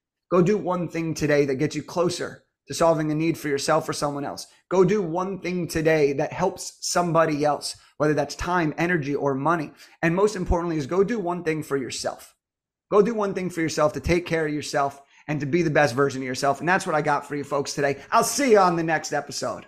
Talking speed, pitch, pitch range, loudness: 240 wpm, 160 Hz, 145-180 Hz, -24 LUFS